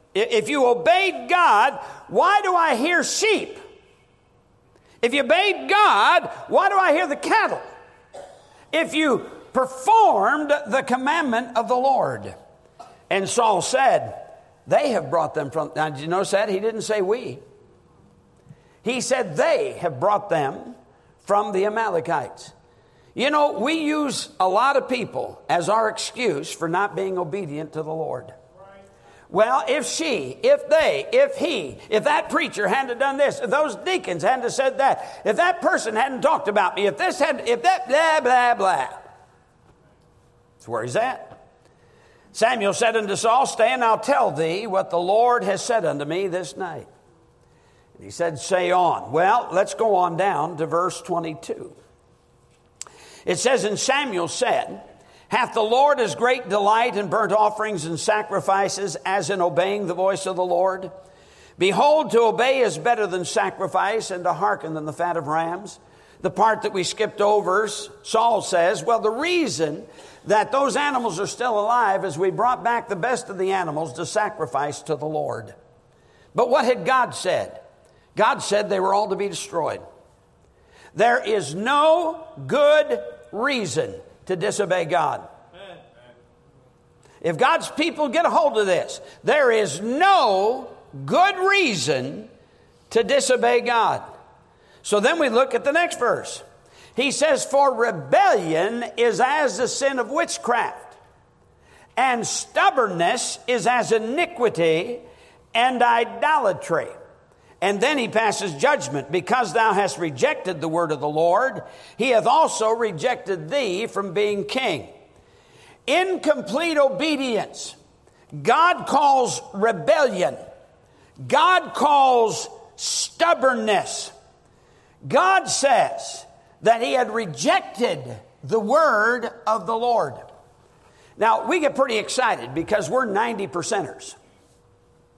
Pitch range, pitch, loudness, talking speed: 190-290 Hz, 230 Hz, -21 LUFS, 145 wpm